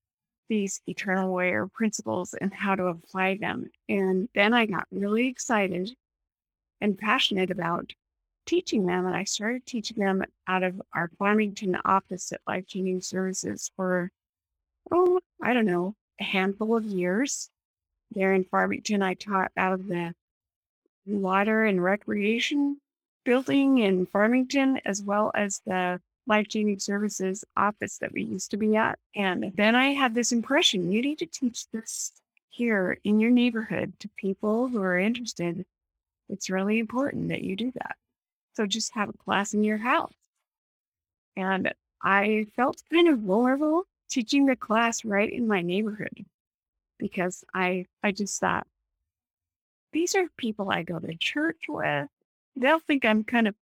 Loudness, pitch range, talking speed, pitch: -26 LUFS, 185-240 Hz, 155 wpm, 205 Hz